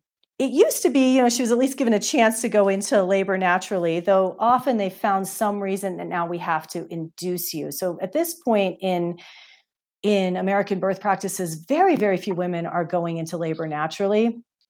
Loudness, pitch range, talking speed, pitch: -22 LUFS, 175-225 Hz, 200 wpm, 195 Hz